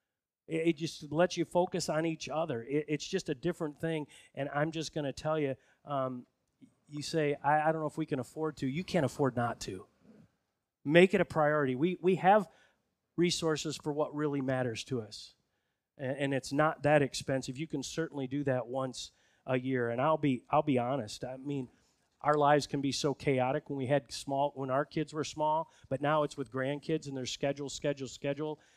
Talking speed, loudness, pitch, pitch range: 205 wpm, -33 LUFS, 145 Hz, 135-155 Hz